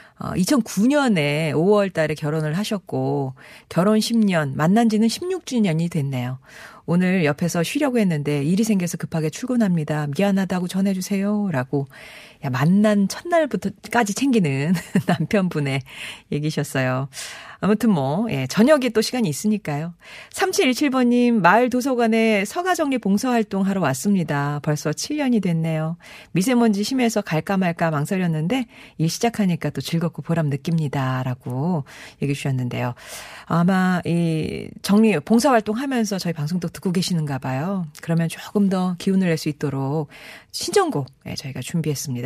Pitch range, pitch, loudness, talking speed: 155-215 Hz, 180 Hz, -21 LUFS, 315 characters per minute